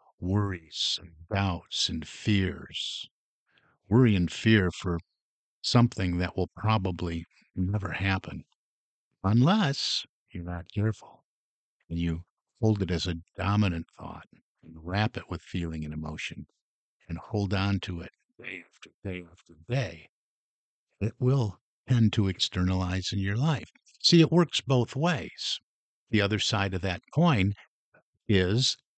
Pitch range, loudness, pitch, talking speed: 90-110 Hz, -28 LUFS, 95 Hz, 135 wpm